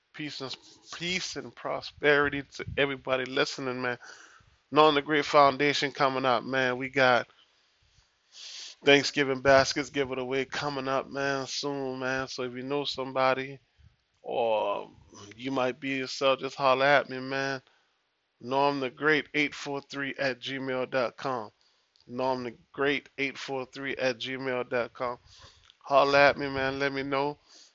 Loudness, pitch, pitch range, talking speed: -28 LUFS, 135 Hz, 130-140 Hz, 135 wpm